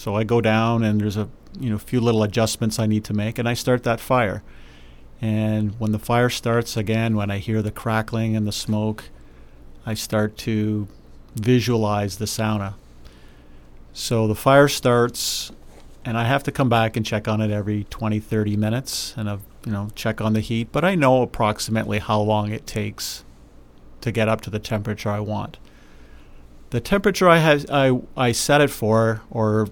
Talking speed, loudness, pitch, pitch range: 190 wpm, -21 LUFS, 110 Hz, 105-115 Hz